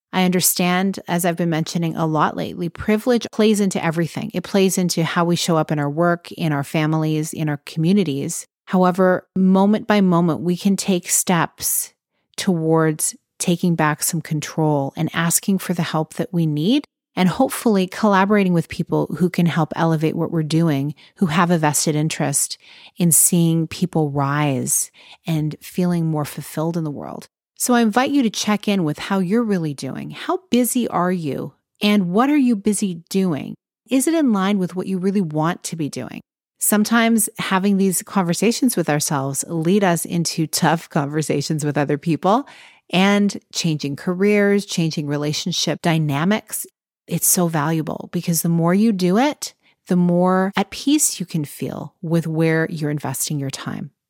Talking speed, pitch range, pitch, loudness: 170 wpm, 160-195 Hz, 175 Hz, -19 LUFS